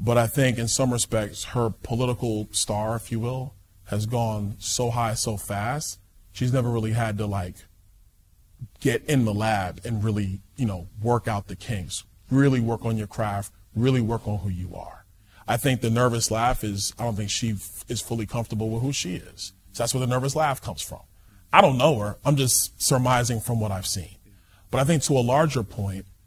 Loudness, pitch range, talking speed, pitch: -25 LUFS, 100-120 Hz, 205 wpm, 110 Hz